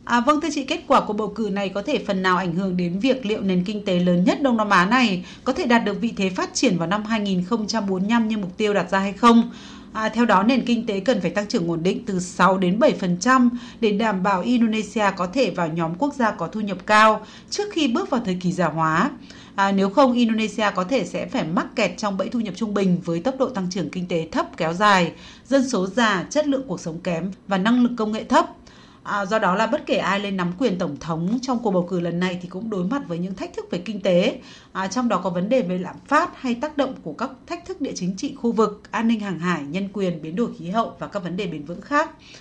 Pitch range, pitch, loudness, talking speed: 185-245 Hz, 210 Hz, -22 LUFS, 270 wpm